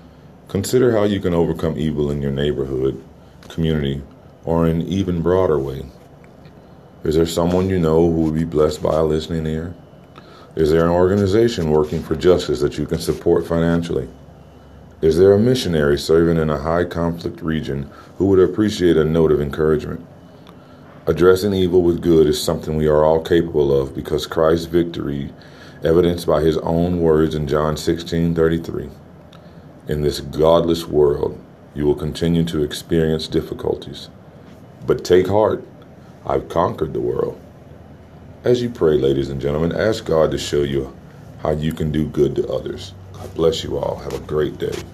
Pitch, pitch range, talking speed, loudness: 80 Hz, 75-85 Hz, 165 wpm, -18 LUFS